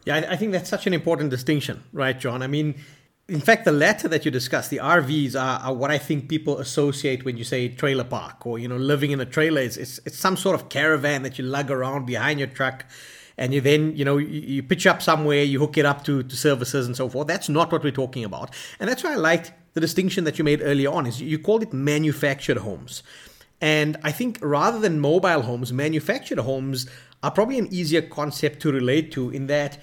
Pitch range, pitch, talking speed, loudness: 135-155 Hz, 145 Hz, 235 wpm, -23 LUFS